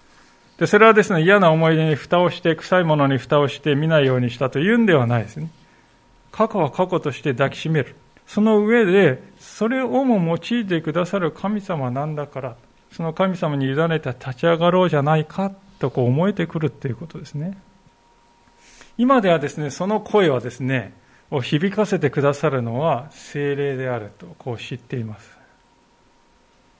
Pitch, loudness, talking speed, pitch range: 160 Hz, -19 LUFS, 340 characters per minute, 135-190 Hz